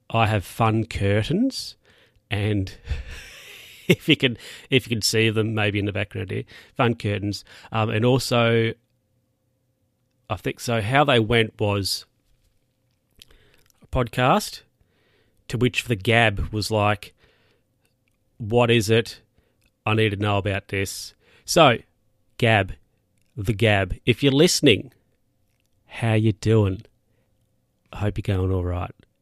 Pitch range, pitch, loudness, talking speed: 105-125 Hz, 110 Hz, -22 LUFS, 130 wpm